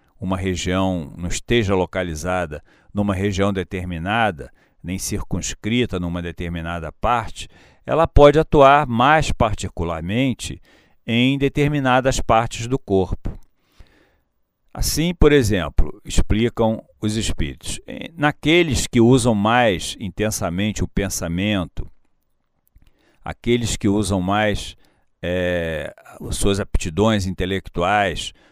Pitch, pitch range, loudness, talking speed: 100 Hz, 90-120 Hz, -20 LUFS, 95 wpm